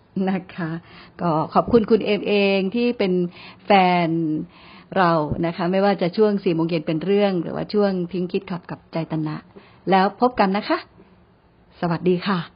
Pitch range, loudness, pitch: 170-200 Hz, -21 LUFS, 180 Hz